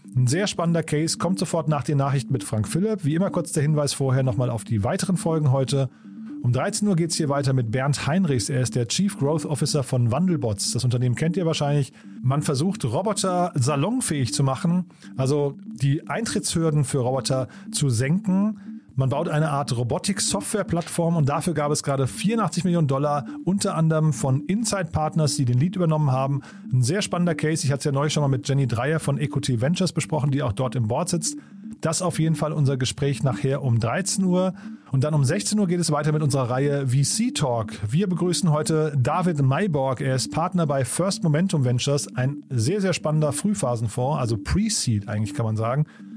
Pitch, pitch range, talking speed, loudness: 150 Hz, 135-175 Hz, 200 wpm, -23 LUFS